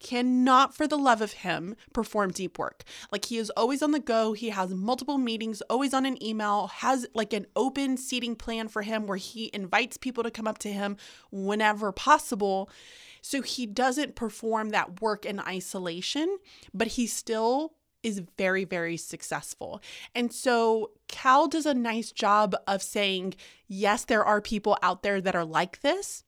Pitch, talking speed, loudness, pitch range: 225 Hz, 175 wpm, -28 LUFS, 205-255 Hz